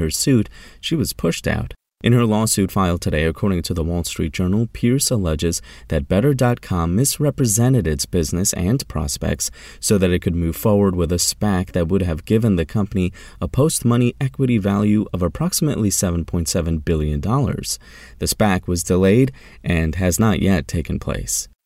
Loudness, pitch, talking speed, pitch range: -19 LUFS, 95 Hz, 165 wpm, 85-110 Hz